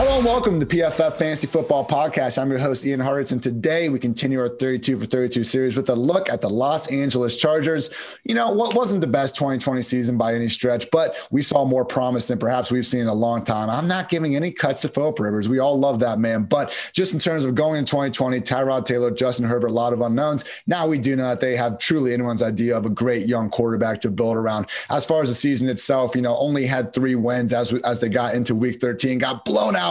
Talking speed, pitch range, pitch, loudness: 250 wpm, 120-145 Hz, 130 Hz, -21 LUFS